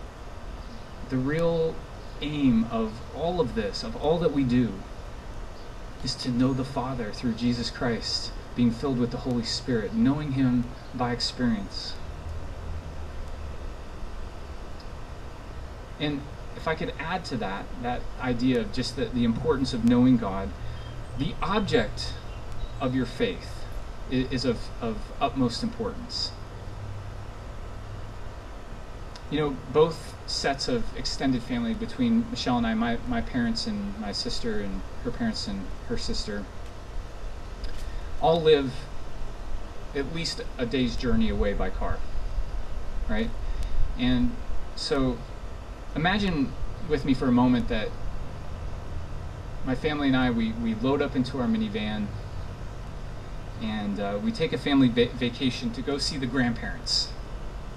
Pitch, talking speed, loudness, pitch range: 115 Hz, 130 wpm, -28 LUFS, 95-130 Hz